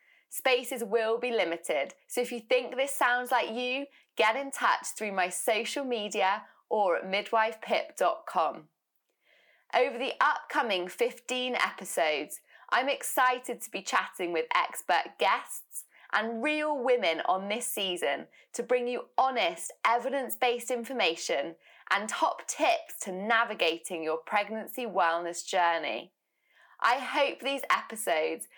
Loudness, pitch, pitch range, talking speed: -29 LUFS, 240 Hz, 205-265 Hz, 130 wpm